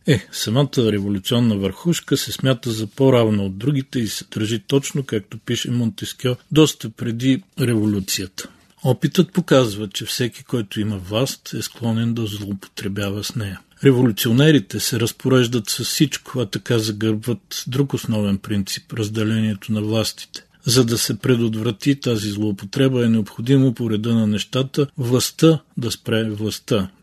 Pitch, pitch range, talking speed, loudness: 115 Hz, 105-130 Hz, 140 wpm, -20 LUFS